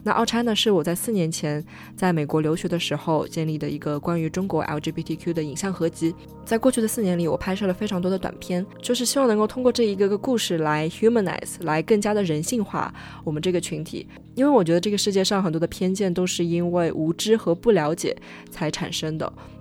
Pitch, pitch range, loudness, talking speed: 175 Hz, 160-210 Hz, -23 LUFS, 365 characters per minute